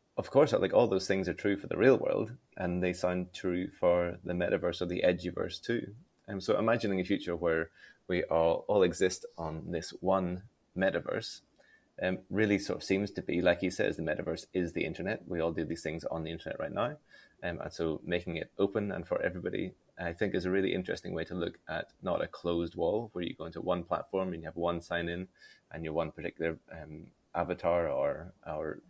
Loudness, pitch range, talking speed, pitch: -33 LUFS, 85-95 Hz, 220 wpm, 90 Hz